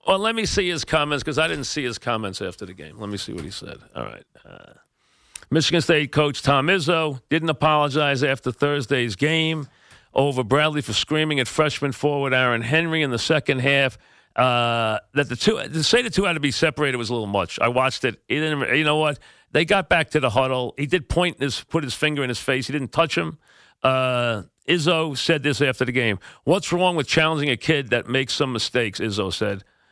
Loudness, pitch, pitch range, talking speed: -21 LUFS, 145 Hz, 130-160 Hz, 220 wpm